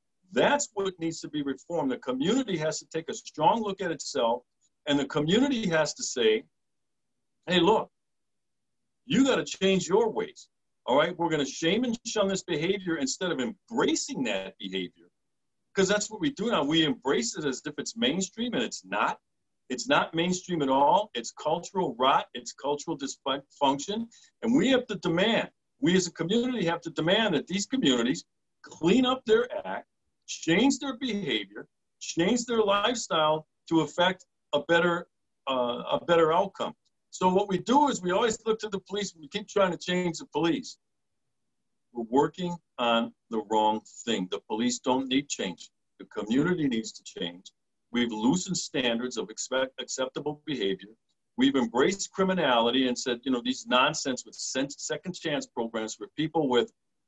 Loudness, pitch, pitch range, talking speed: -28 LUFS, 175 Hz, 140-220 Hz, 170 wpm